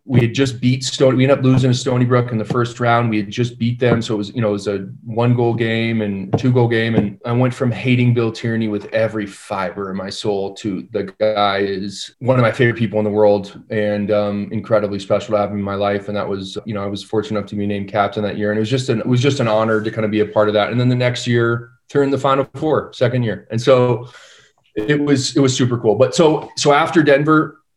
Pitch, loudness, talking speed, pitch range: 115 Hz, -17 LUFS, 275 wpm, 105-125 Hz